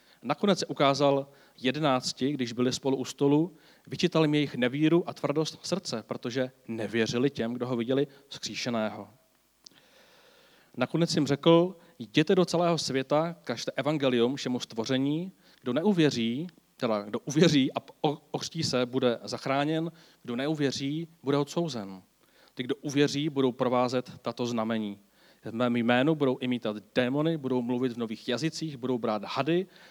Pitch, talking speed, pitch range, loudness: 135 Hz, 140 wpm, 125-155 Hz, -29 LUFS